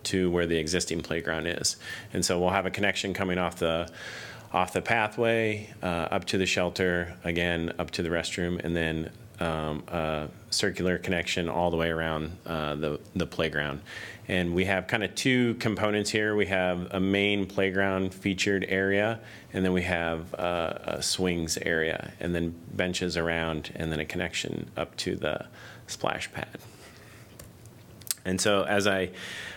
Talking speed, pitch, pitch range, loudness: 165 wpm, 90 Hz, 85-100 Hz, -28 LUFS